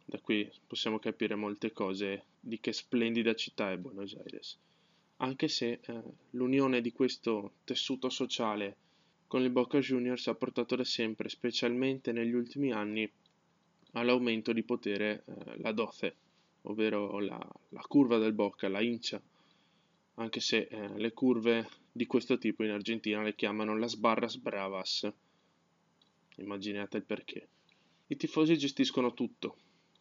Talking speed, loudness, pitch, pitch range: 140 wpm, -34 LUFS, 115 Hz, 105-125 Hz